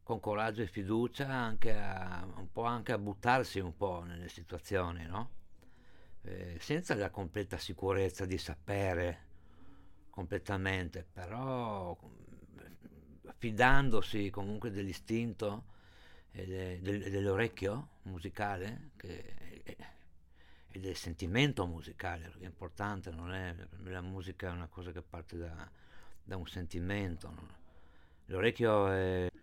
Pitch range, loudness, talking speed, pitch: 85-105 Hz, -37 LUFS, 110 wpm, 95 Hz